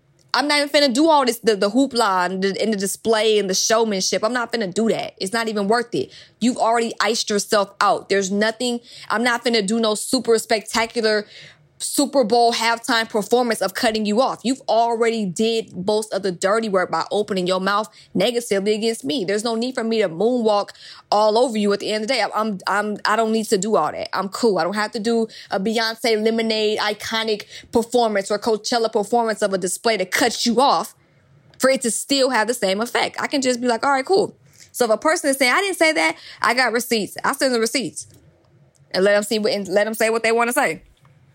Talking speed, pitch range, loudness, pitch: 230 wpm, 205-240 Hz, -20 LUFS, 225 Hz